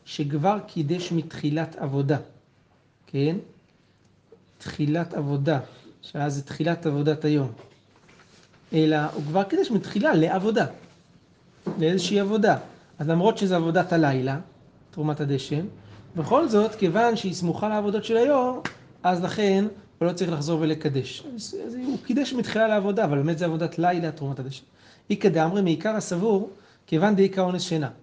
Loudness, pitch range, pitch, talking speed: -25 LUFS, 150-205 Hz, 170 Hz, 135 wpm